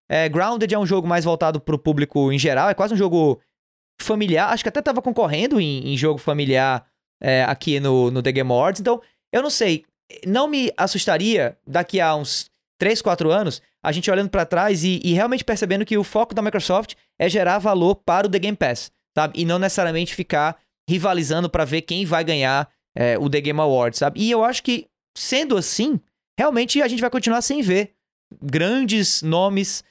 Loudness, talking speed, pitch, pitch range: -20 LUFS, 205 wpm, 180 Hz, 155-215 Hz